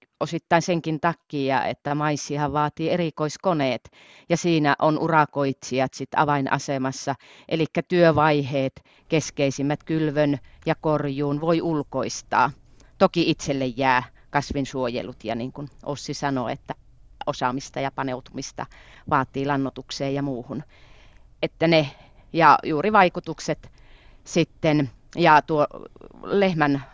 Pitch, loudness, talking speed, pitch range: 145 Hz, -23 LUFS, 105 wpm, 130-155 Hz